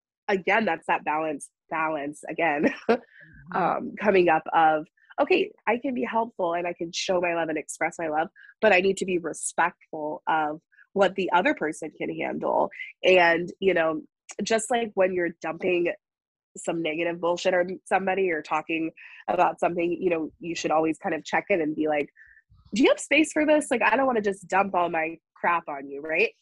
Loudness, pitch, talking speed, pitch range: -25 LUFS, 175 Hz, 195 wpm, 160-195 Hz